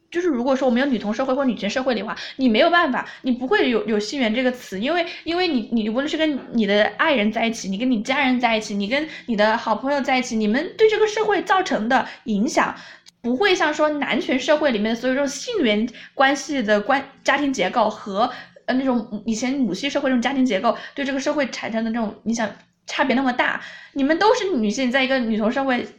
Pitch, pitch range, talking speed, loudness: 260 Hz, 225-290 Hz, 350 characters per minute, -21 LUFS